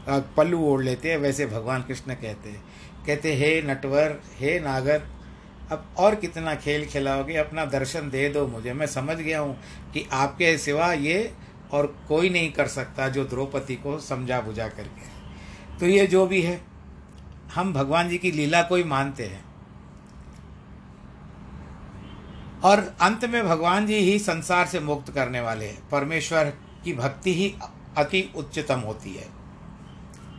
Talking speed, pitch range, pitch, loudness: 150 wpm, 125-165 Hz, 145 Hz, -24 LUFS